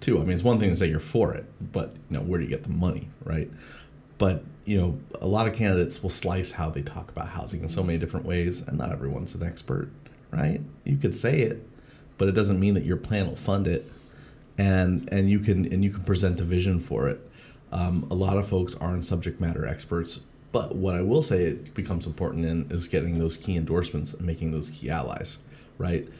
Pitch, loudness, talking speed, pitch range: 90 Hz, -27 LUFS, 230 wpm, 85-95 Hz